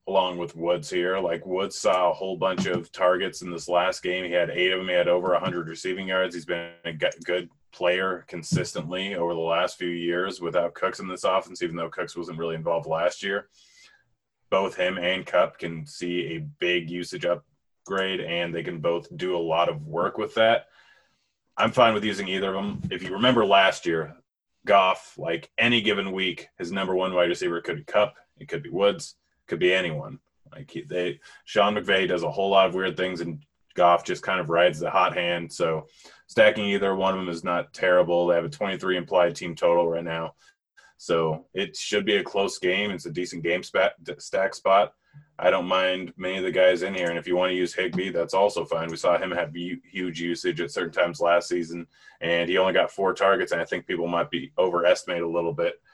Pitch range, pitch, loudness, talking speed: 85-95 Hz, 90 Hz, -25 LUFS, 215 wpm